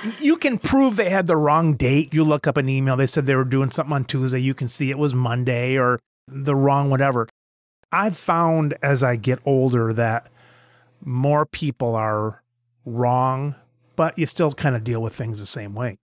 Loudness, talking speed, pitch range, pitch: -21 LUFS, 200 wpm, 125-150 Hz, 135 Hz